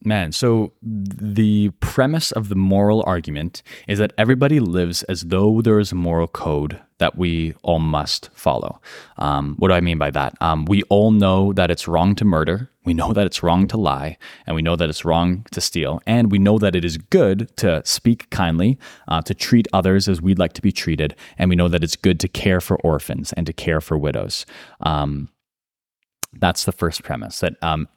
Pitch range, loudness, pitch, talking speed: 80-105 Hz, -19 LUFS, 90 Hz, 210 wpm